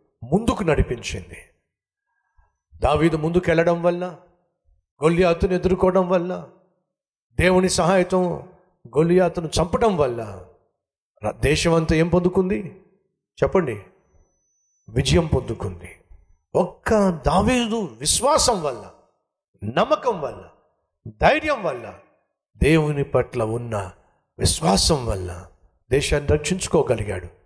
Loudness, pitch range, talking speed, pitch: -21 LUFS, 120-185 Hz, 75 wpm, 170 Hz